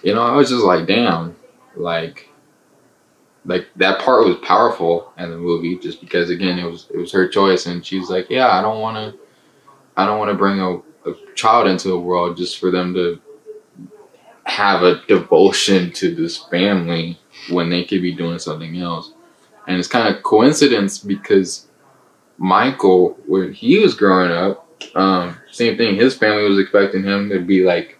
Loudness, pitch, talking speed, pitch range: -16 LUFS, 90 Hz, 175 wpm, 85-100 Hz